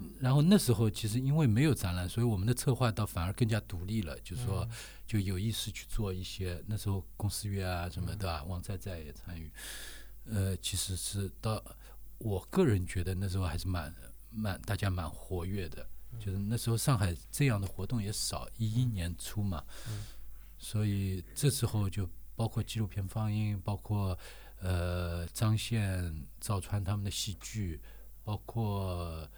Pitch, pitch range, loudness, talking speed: 100 Hz, 90-110 Hz, -34 LUFS, 255 characters per minute